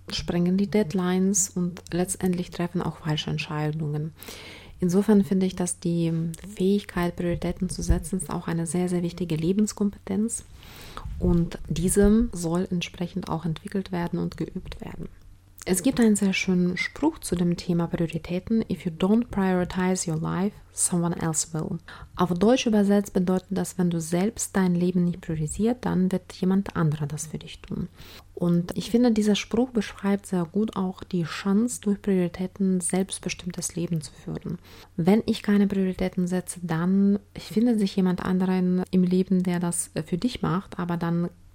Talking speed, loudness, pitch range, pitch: 160 wpm, -25 LUFS, 175-195 Hz, 185 Hz